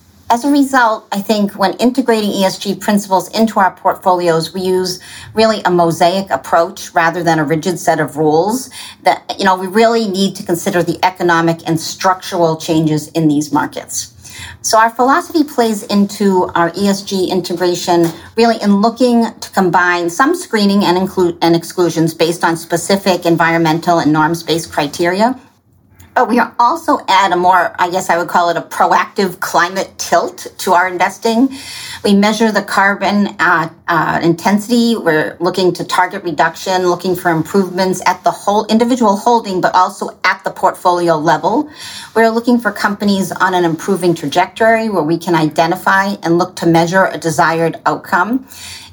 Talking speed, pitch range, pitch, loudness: 165 wpm, 170-205 Hz, 185 Hz, -13 LUFS